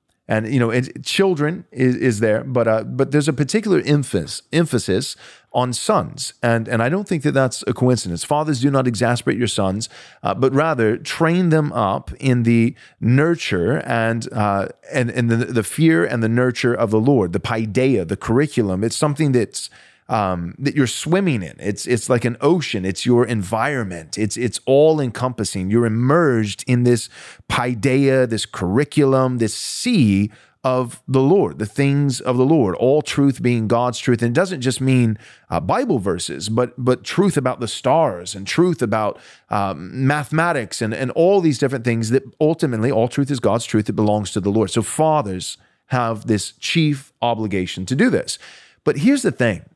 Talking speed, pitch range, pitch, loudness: 180 wpm, 110-140 Hz, 125 Hz, -19 LUFS